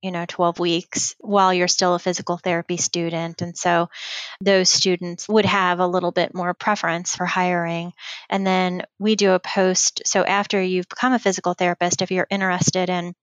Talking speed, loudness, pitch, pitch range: 185 wpm, -20 LUFS, 180 Hz, 175-190 Hz